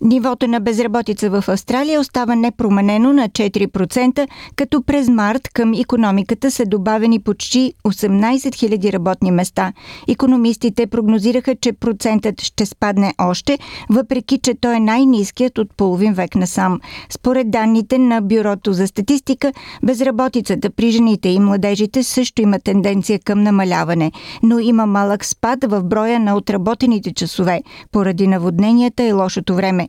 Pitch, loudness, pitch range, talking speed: 225 Hz, -16 LUFS, 200-250 Hz, 135 wpm